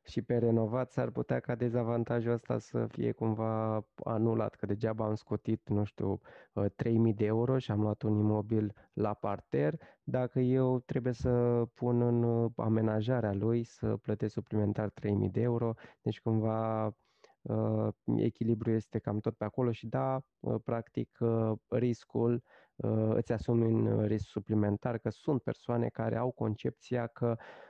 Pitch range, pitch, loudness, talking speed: 110-120 Hz, 115 Hz, -33 LUFS, 145 wpm